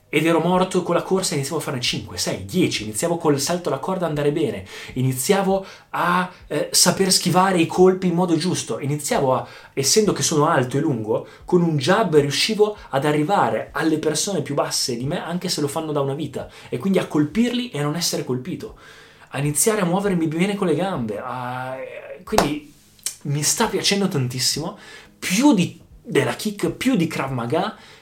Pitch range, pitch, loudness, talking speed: 145-185 Hz, 160 Hz, -21 LUFS, 190 wpm